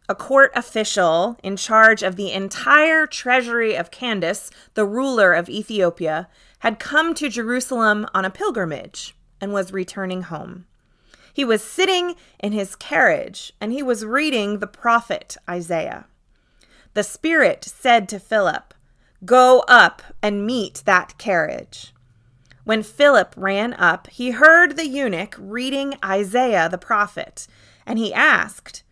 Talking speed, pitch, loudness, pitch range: 135 wpm, 215 Hz, -18 LUFS, 190-255 Hz